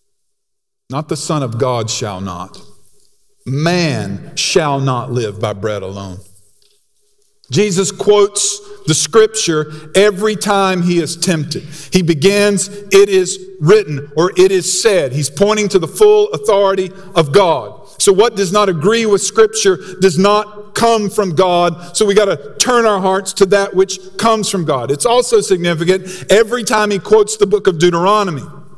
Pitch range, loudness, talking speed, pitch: 165-210 Hz, -13 LUFS, 160 wpm, 195 Hz